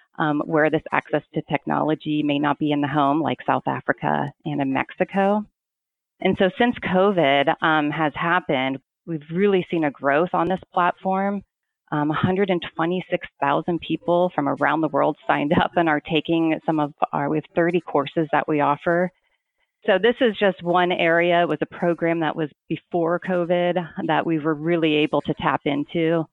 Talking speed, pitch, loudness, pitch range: 175 wpm, 165 Hz, -22 LUFS, 150-180 Hz